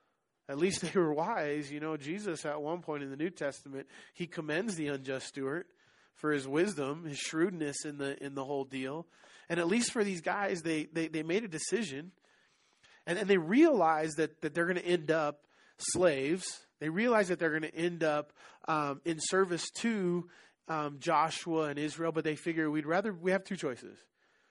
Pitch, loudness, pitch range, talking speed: 160 Hz, -33 LUFS, 150-175 Hz, 195 wpm